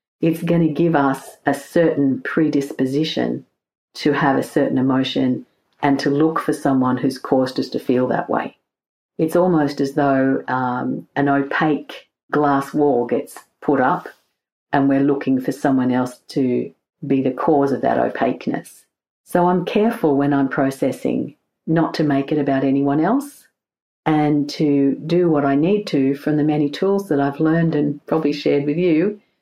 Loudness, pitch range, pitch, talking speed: -19 LUFS, 135-160 Hz, 145 Hz, 165 wpm